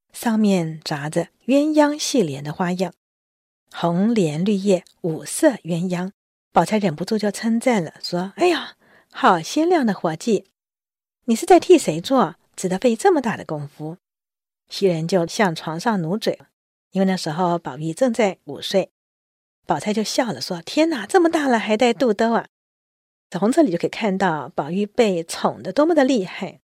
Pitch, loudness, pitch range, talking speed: 195 Hz, -20 LUFS, 170-235 Hz, 240 characters per minute